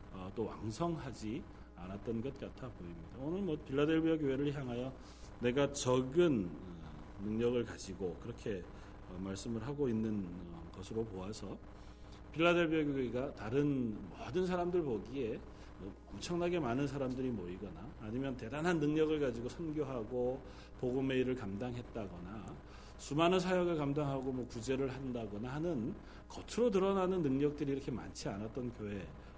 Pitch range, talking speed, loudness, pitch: 100-145 Hz, 315 characters per minute, -38 LUFS, 125 Hz